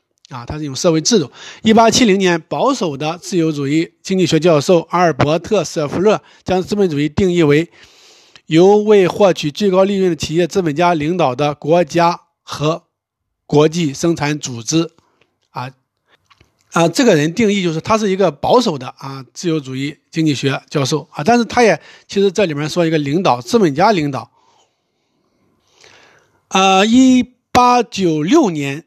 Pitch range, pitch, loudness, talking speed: 150-195 Hz, 170 Hz, -14 LUFS, 245 characters per minute